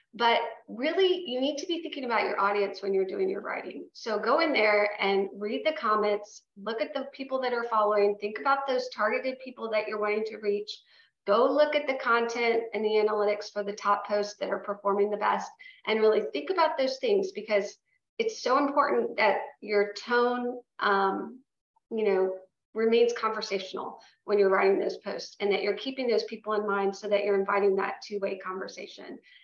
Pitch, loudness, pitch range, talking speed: 220 Hz, -28 LUFS, 205-265 Hz, 195 wpm